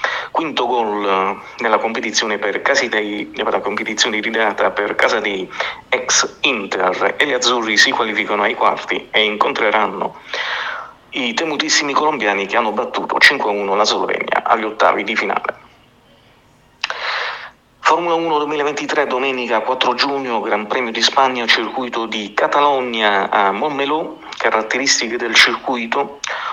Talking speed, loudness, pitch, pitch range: 120 wpm, -16 LUFS, 120 Hz, 105-140 Hz